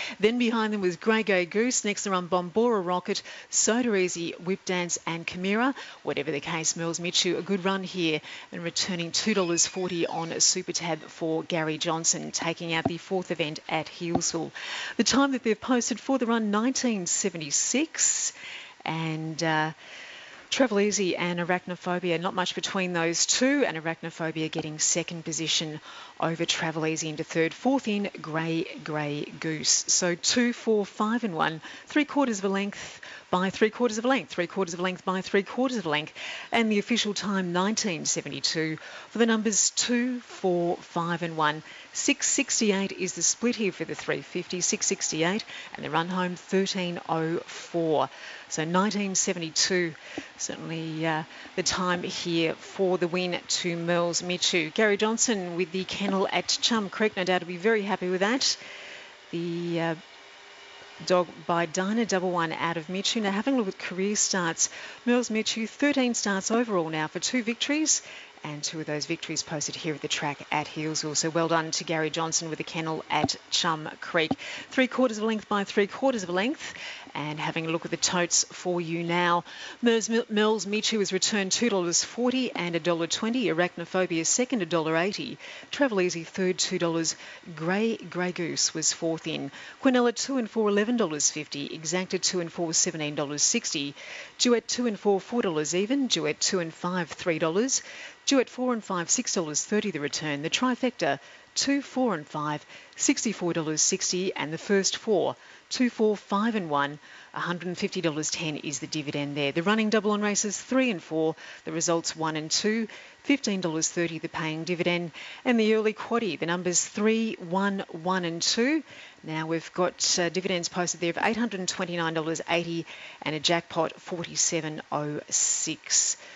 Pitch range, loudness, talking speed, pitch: 165-215 Hz, -27 LUFS, 160 wpm, 180 Hz